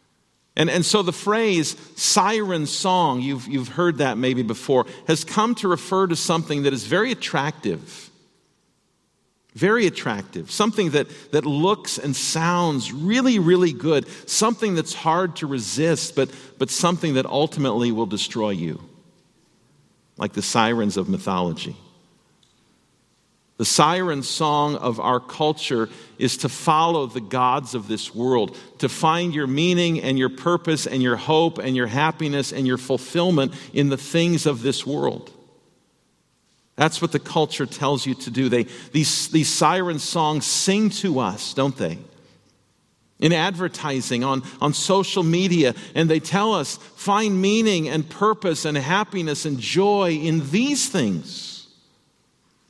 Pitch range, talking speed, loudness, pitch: 130-175 Hz, 145 wpm, -21 LUFS, 155 Hz